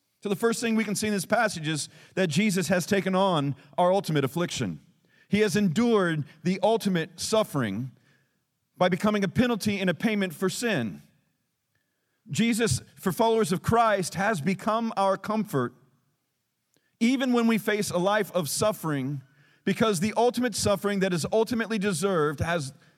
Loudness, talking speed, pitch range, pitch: -26 LUFS, 155 wpm, 165-215 Hz, 195 Hz